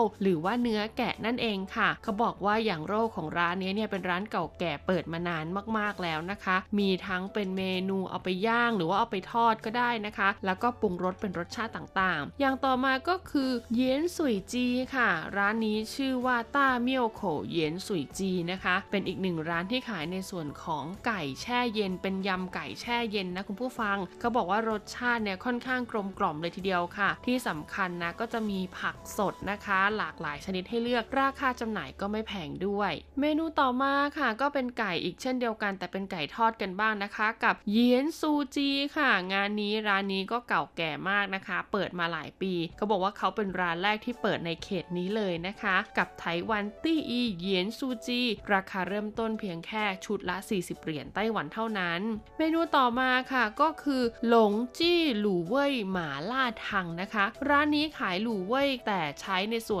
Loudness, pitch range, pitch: -30 LUFS, 185-240 Hz, 210 Hz